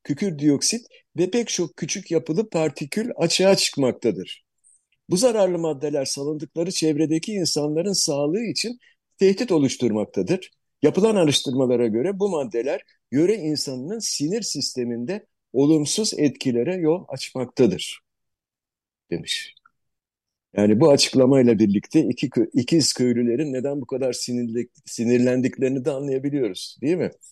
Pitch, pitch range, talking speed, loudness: 150 Hz, 130-180 Hz, 110 wpm, -22 LUFS